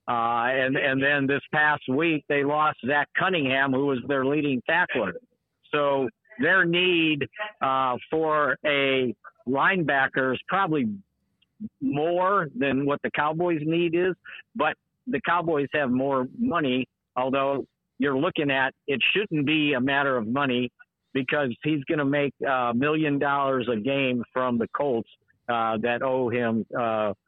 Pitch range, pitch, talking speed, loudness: 130-155 Hz, 140 Hz, 145 wpm, -24 LUFS